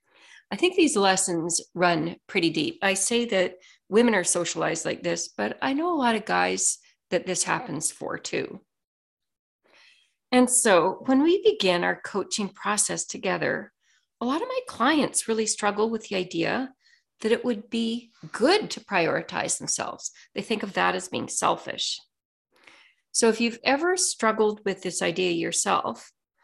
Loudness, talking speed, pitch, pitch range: -25 LUFS, 160 wpm, 215 Hz, 180-255 Hz